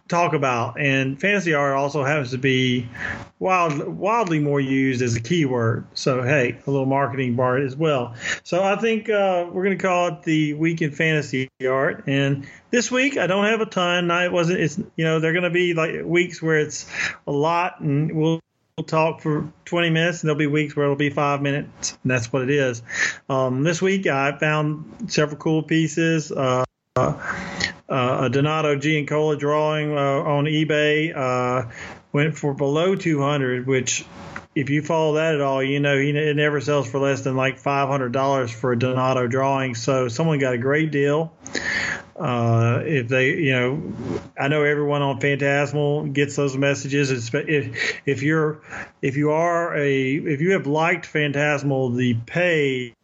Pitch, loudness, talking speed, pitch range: 145 Hz, -21 LUFS, 180 wpm, 135-160 Hz